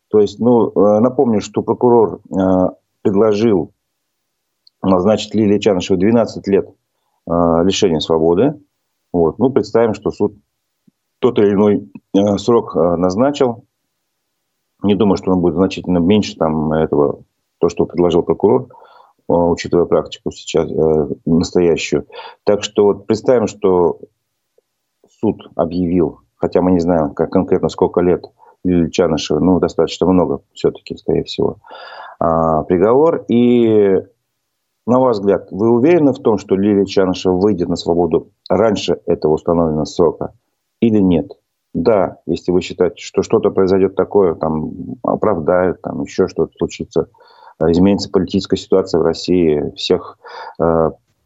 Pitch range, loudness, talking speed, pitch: 85-105 Hz, -15 LUFS, 130 wpm, 90 Hz